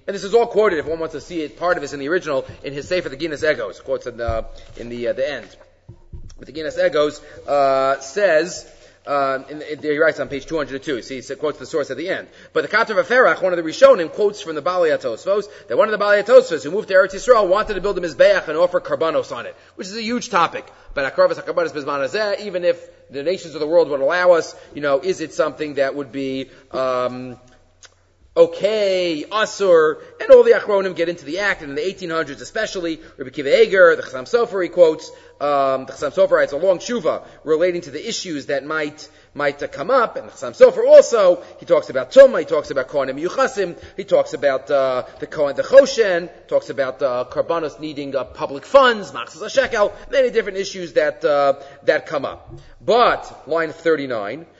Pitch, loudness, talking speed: 180 Hz, -18 LUFS, 220 wpm